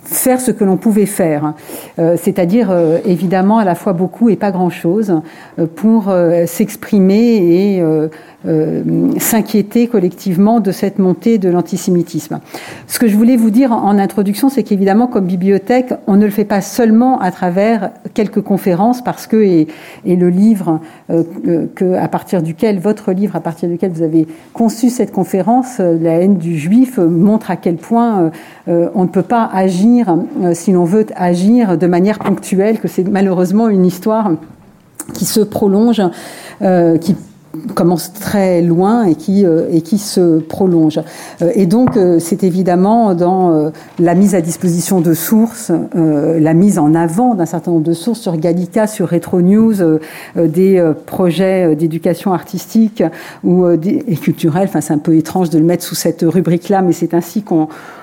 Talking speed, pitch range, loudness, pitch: 165 wpm, 170-210 Hz, -13 LUFS, 185 Hz